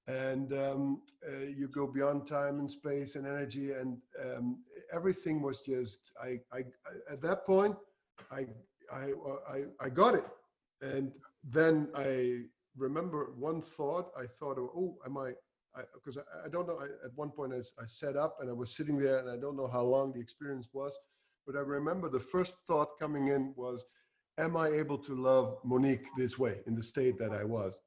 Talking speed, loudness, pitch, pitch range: 195 wpm, -36 LUFS, 140 Hz, 130-150 Hz